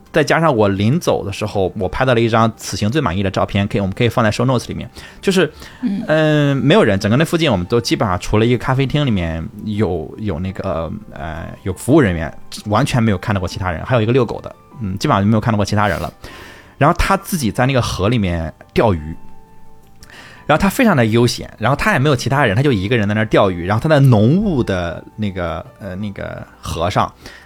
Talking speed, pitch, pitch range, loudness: 355 characters per minute, 110 Hz, 95-130 Hz, -16 LUFS